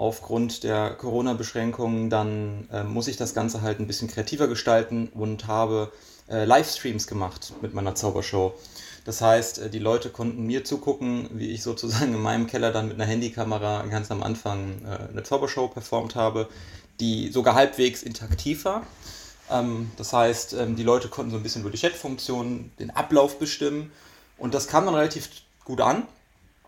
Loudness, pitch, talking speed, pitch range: -26 LUFS, 115 Hz, 175 wpm, 110-125 Hz